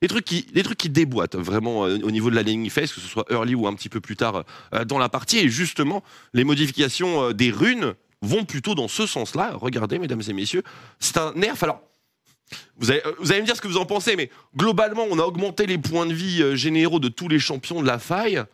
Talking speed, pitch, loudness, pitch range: 240 wpm, 155 Hz, -22 LUFS, 120-185 Hz